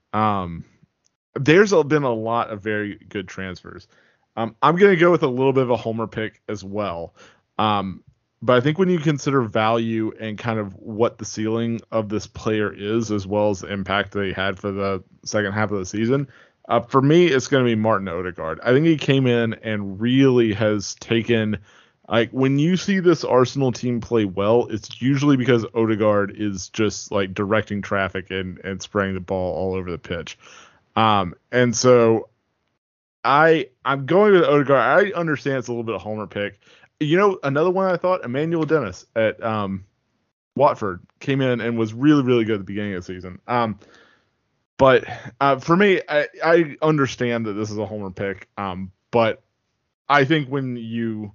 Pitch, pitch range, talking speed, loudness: 115 Hz, 105-135 Hz, 190 wpm, -20 LUFS